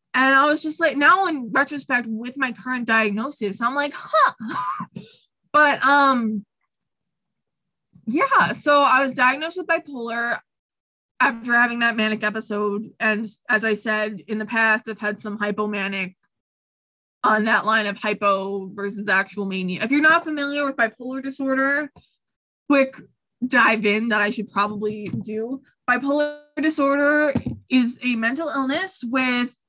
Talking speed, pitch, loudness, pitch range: 140 wpm, 240 Hz, -21 LUFS, 215-275 Hz